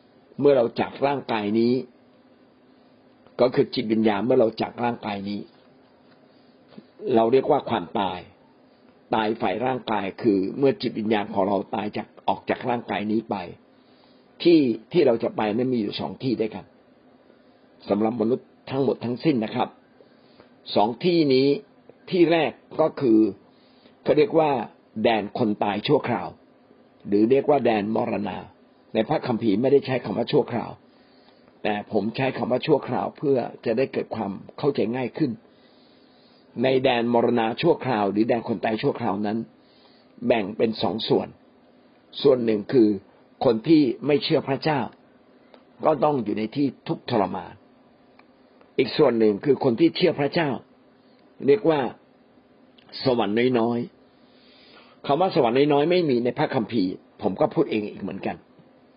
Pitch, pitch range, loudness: 120 Hz, 110-140 Hz, -23 LUFS